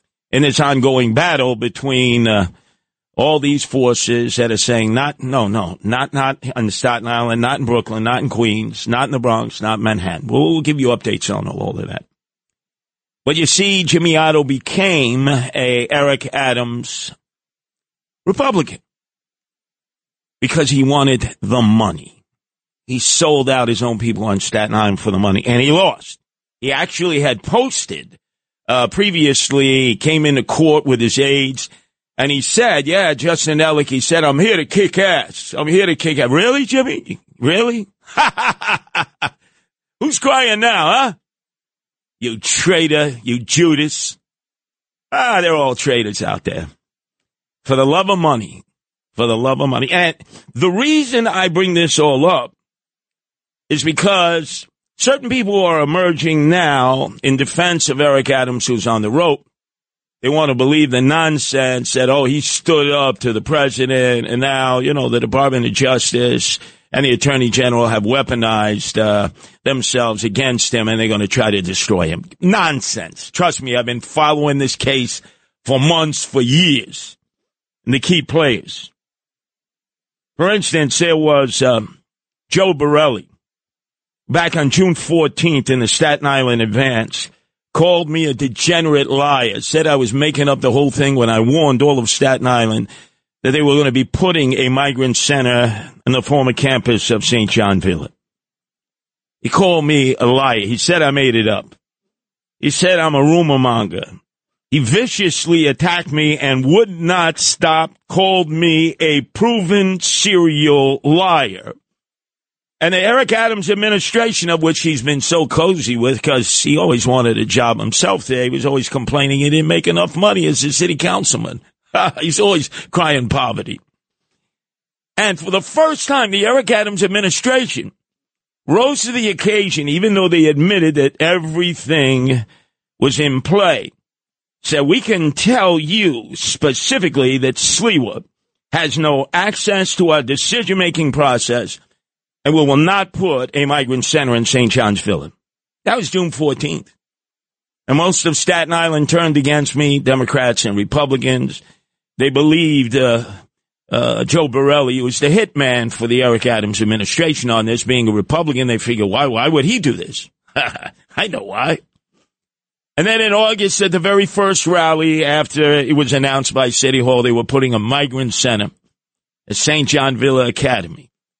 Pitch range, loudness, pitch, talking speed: 125-165 Hz, -14 LUFS, 140 Hz, 160 wpm